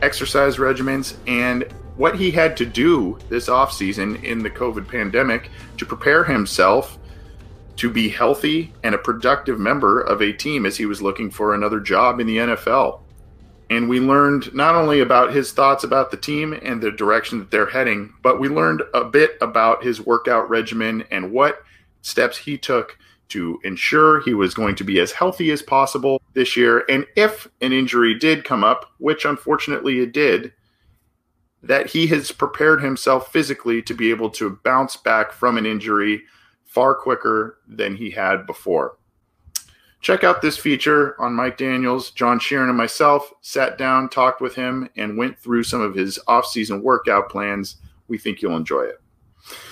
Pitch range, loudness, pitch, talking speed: 110-140 Hz, -18 LUFS, 125 Hz, 175 wpm